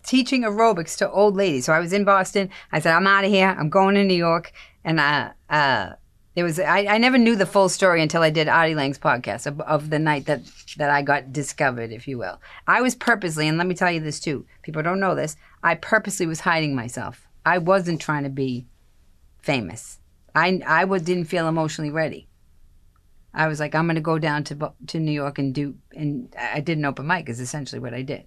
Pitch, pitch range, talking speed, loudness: 155 Hz, 140-185 Hz, 225 wpm, -21 LUFS